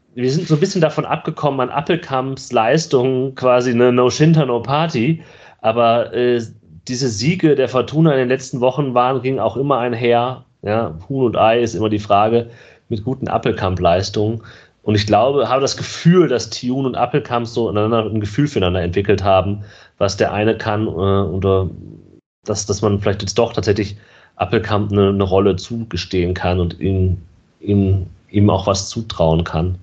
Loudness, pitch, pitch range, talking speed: -17 LUFS, 115 Hz, 100-130 Hz, 175 wpm